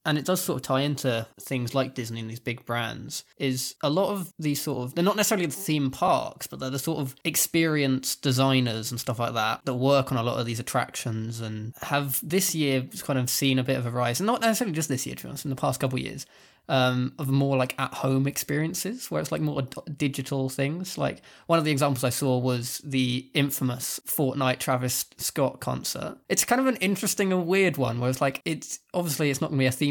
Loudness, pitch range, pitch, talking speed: -26 LUFS, 130-155 Hz, 135 Hz, 235 wpm